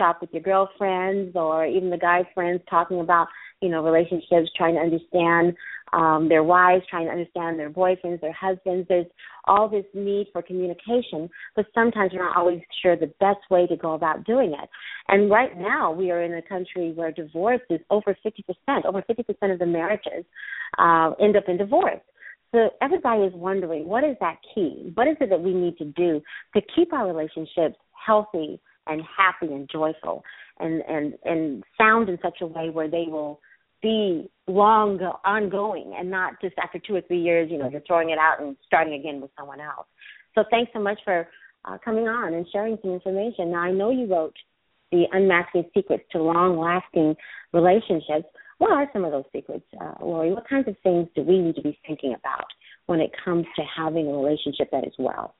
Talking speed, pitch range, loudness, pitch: 195 wpm, 165-200 Hz, -23 LUFS, 180 Hz